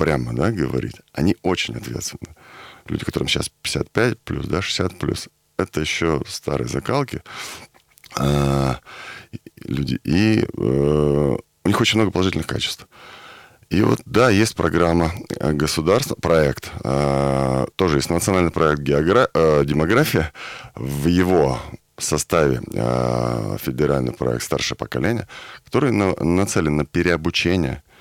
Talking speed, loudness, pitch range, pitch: 120 wpm, -20 LUFS, 70-90 Hz, 75 Hz